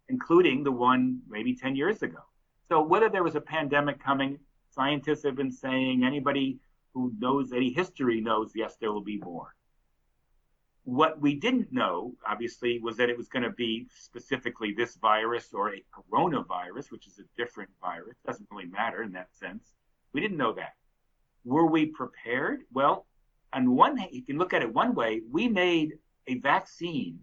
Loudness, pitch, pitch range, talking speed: -28 LUFS, 135 Hz, 120-160 Hz, 175 wpm